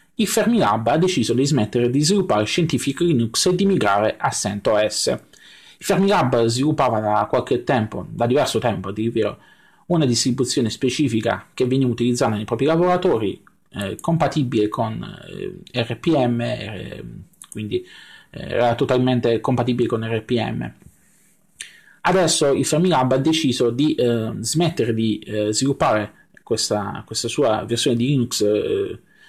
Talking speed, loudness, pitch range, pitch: 130 wpm, -20 LUFS, 110-150 Hz, 125 Hz